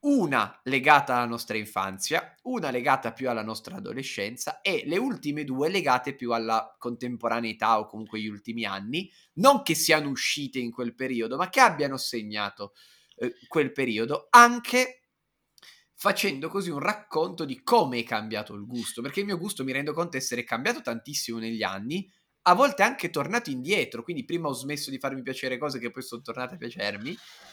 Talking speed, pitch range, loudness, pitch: 175 wpm, 115-180 Hz, -26 LUFS, 130 Hz